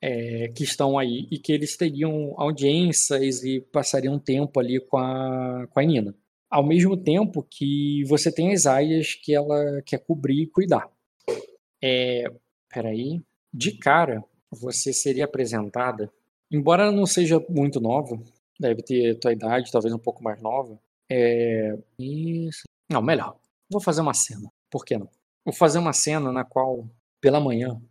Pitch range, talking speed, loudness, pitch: 125-155 Hz, 155 wpm, -23 LUFS, 140 Hz